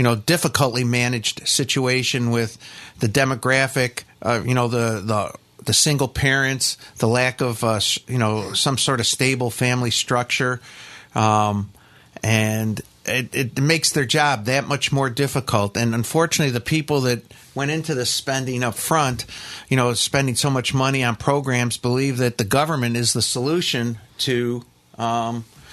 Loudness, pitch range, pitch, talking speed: -20 LUFS, 115-135 Hz, 125 Hz, 155 wpm